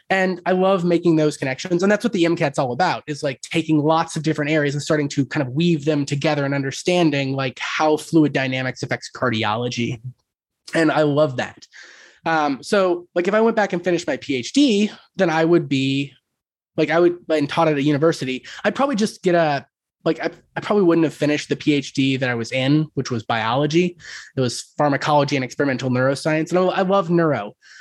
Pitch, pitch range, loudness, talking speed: 155 Hz, 135-170 Hz, -20 LUFS, 205 wpm